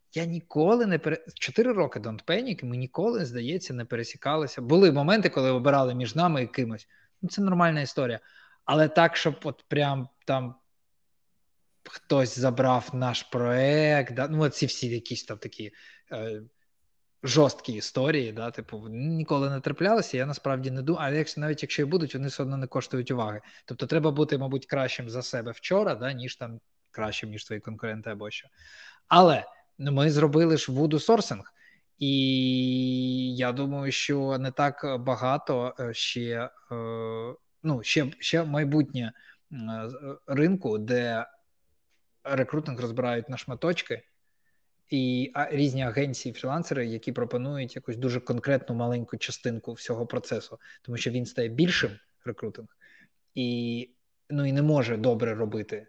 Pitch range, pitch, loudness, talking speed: 120-150 Hz, 130 Hz, -27 LUFS, 140 wpm